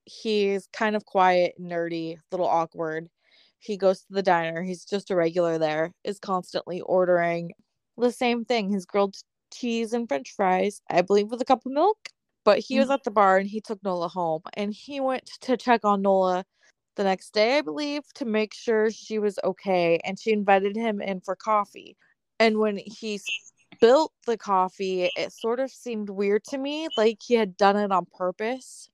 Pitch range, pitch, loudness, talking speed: 185-230 Hz, 205 Hz, -25 LUFS, 195 wpm